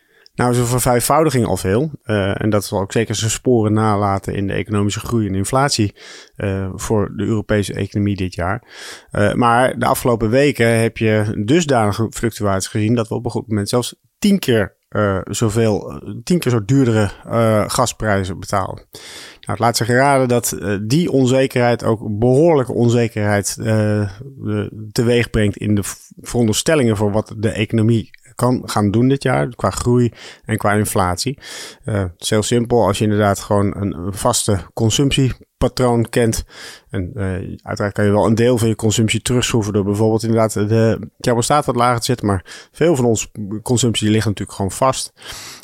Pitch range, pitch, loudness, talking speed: 105-120 Hz, 110 Hz, -17 LUFS, 170 wpm